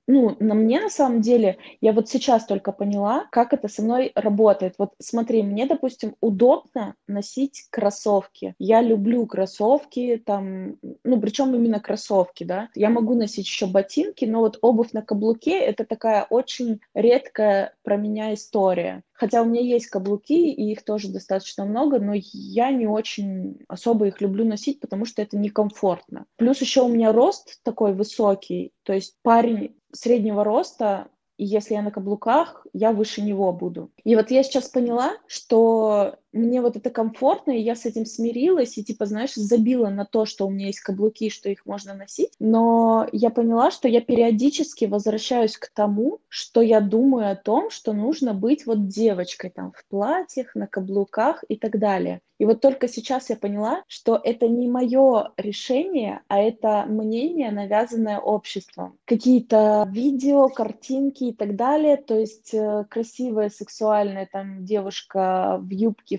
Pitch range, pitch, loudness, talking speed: 205-245 Hz, 225 Hz, -22 LUFS, 165 wpm